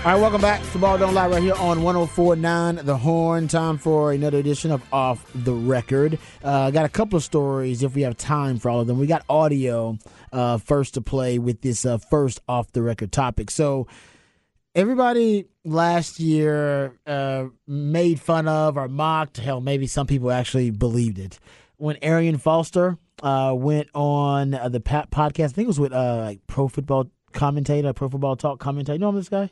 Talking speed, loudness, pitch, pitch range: 195 wpm, -22 LUFS, 145 Hz, 130-160 Hz